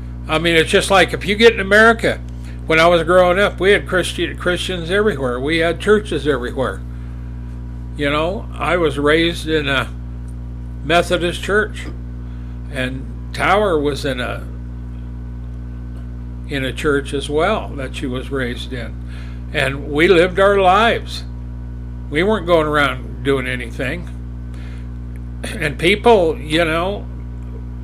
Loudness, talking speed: -16 LUFS, 135 wpm